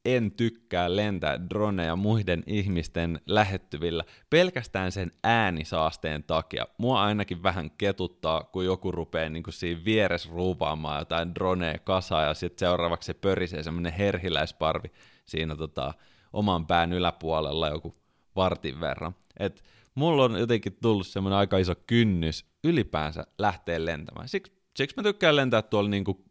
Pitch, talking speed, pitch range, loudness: 90 Hz, 135 wpm, 85-105 Hz, -28 LUFS